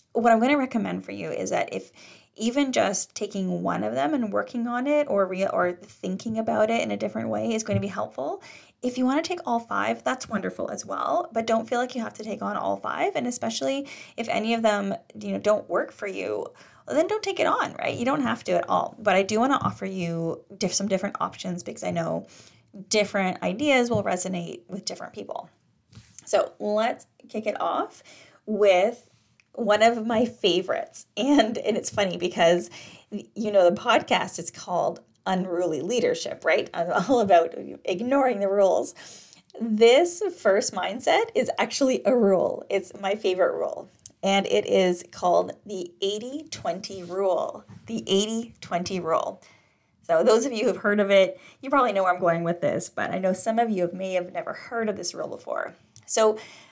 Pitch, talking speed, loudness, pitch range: 210 Hz, 200 wpm, -25 LUFS, 190-245 Hz